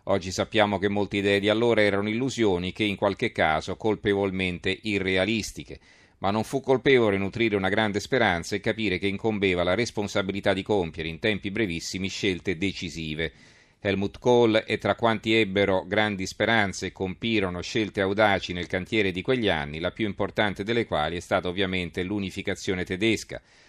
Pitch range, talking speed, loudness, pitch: 95-110 Hz, 160 wpm, -25 LUFS, 100 Hz